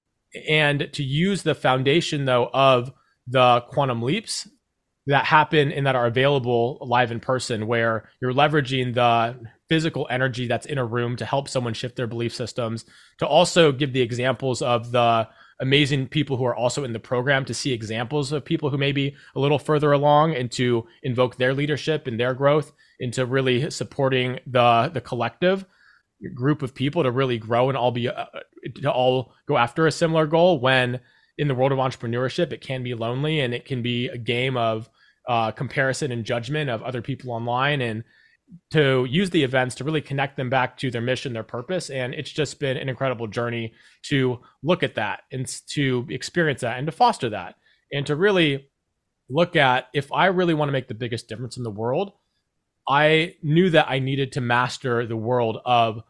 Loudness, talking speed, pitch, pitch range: -22 LUFS, 195 wpm, 130 Hz, 120-150 Hz